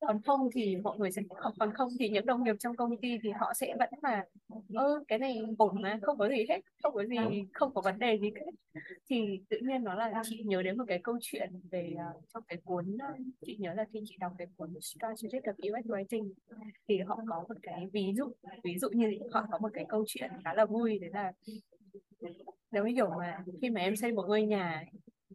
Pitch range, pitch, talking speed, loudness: 195-235 Hz, 215 Hz, 235 wpm, -35 LUFS